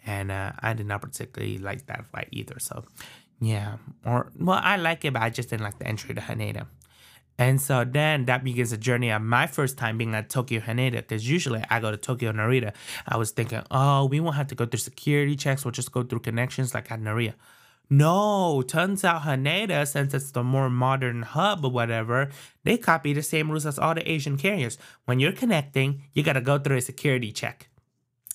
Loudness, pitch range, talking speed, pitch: -26 LUFS, 115-145 Hz, 215 wpm, 130 Hz